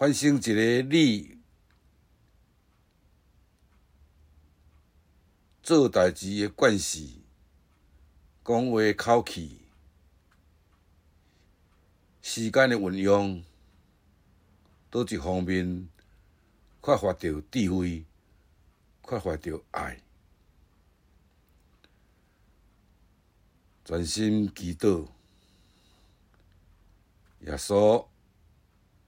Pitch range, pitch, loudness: 80-100 Hz, 90 Hz, -26 LUFS